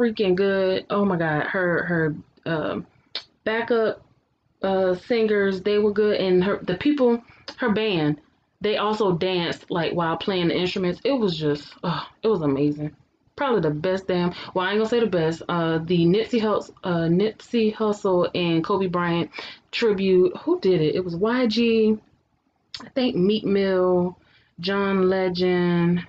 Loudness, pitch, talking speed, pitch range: -23 LUFS, 185 Hz, 160 wpm, 175-215 Hz